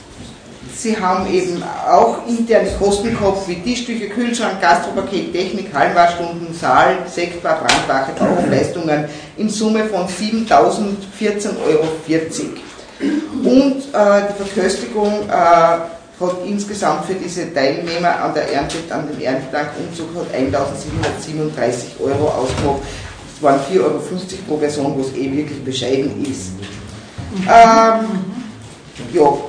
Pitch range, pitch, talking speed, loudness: 150-205 Hz, 175 Hz, 110 wpm, -16 LUFS